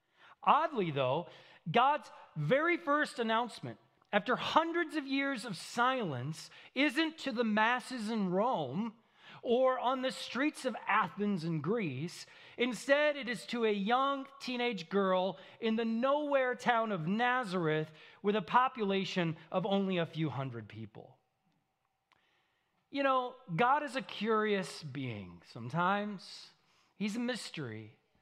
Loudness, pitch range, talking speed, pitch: -33 LUFS, 180-255 Hz, 130 wpm, 225 Hz